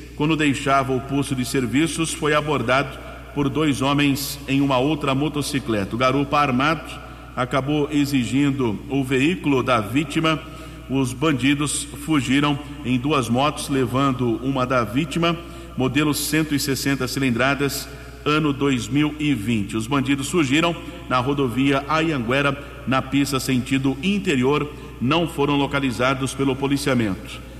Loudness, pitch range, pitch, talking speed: -21 LUFS, 130-145 Hz, 140 Hz, 115 wpm